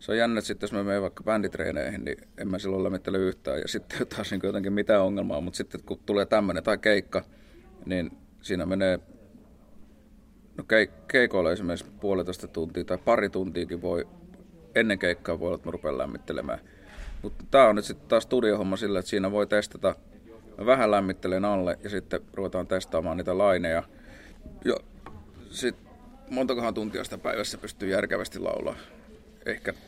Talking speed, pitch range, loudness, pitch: 165 wpm, 95-105 Hz, -28 LUFS, 100 Hz